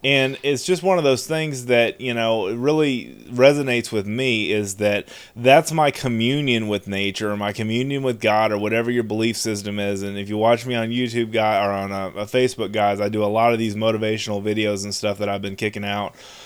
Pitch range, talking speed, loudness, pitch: 105-125 Hz, 220 wpm, -21 LUFS, 110 Hz